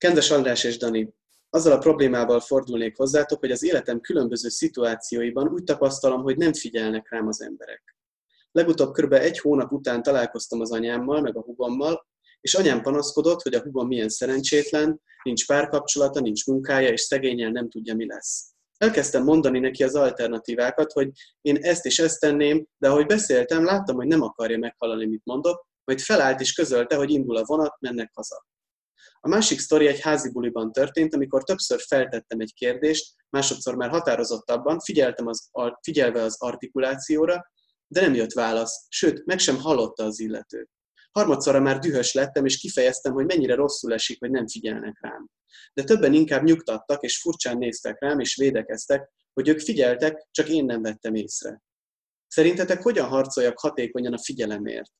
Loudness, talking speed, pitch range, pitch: -23 LUFS, 165 wpm, 120-150 Hz, 135 Hz